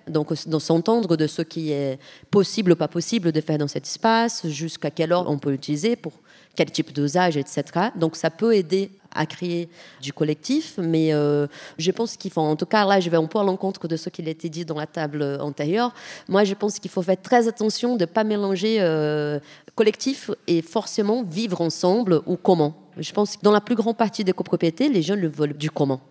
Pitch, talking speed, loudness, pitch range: 175 Hz, 220 wpm, -23 LUFS, 155-210 Hz